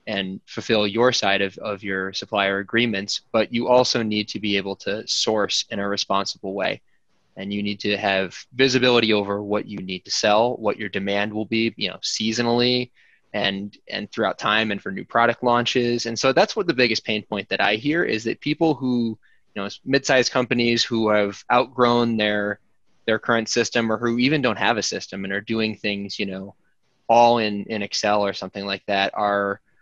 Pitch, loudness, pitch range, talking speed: 110 Hz, -22 LUFS, 100-120 Hz, 200 wpm